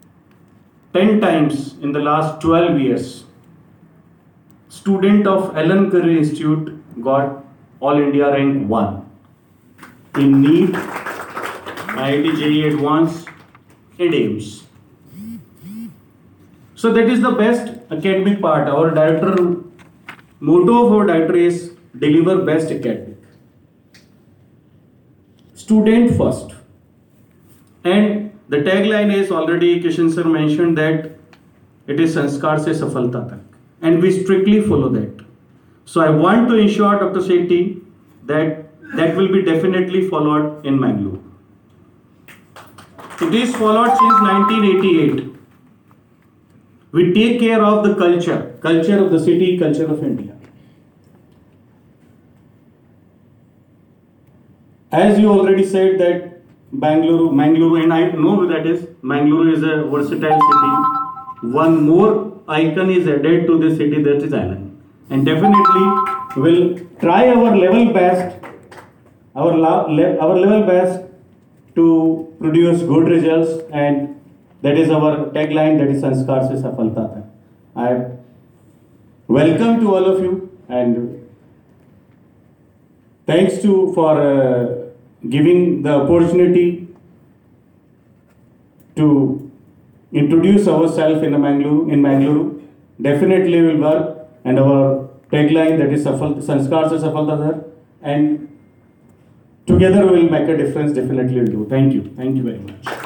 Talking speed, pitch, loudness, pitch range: 105 wpm, 160 Hz, -15 LUFS, 145-185 Hz